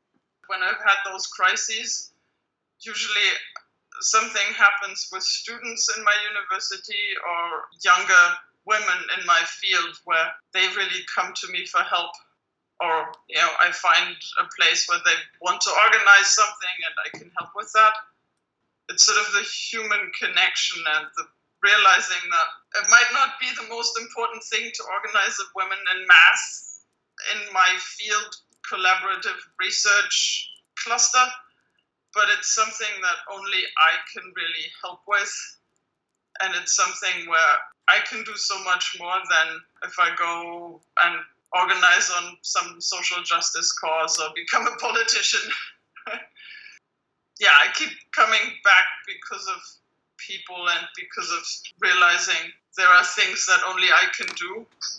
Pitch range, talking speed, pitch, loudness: 180-235 Hz, 145 wpm, 200 Hz, -20 LUFS